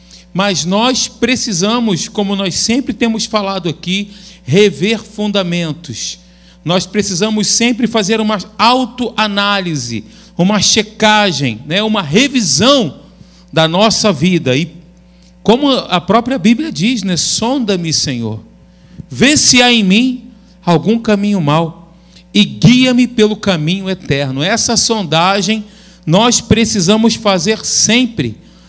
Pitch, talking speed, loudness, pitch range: 200 Hz, 110 wpm, -12 LUFS, 175-220 Hz